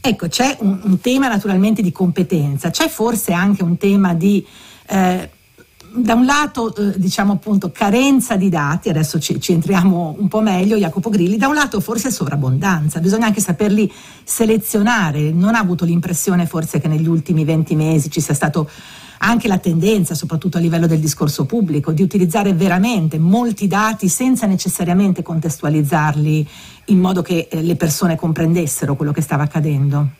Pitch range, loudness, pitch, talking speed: 165-205 Hz, -16 LUFS, 185 Hz, 160 wpm